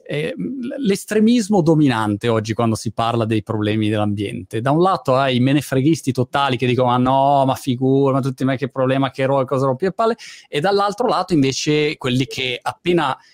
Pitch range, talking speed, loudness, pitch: 125-160 Hz, 195 wpm, -18 LUFS, 135 Hz